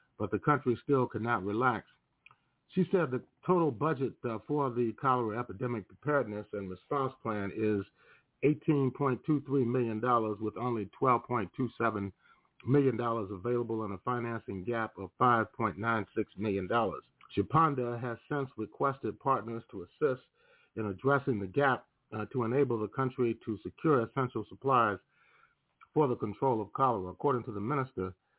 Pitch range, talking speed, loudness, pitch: 110-135 Hz, 130 wpm, -32 LUFS, 120 Hz